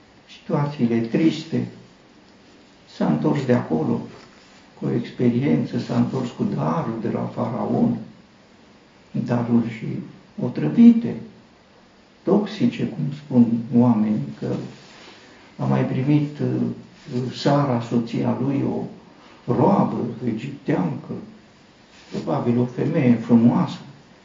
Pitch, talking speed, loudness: 120 Hz, 95 wpm, -22 LUFS